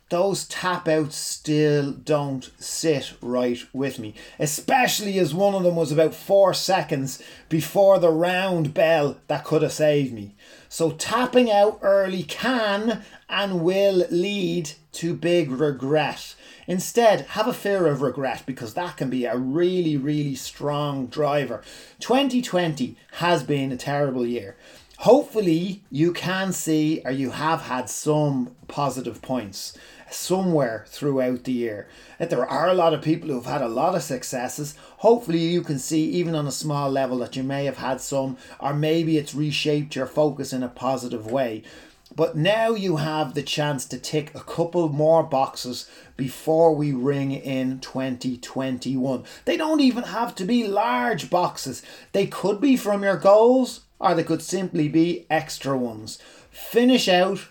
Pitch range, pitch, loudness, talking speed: 135-180 Hz, 155 Hz, -23 LUFS, 160 wpm